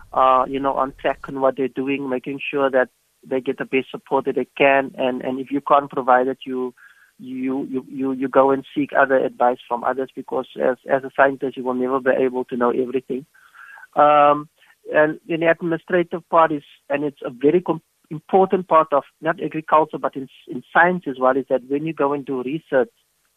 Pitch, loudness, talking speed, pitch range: 135 Hz, -20 LUFS, 210 wpm, 130-155 Hz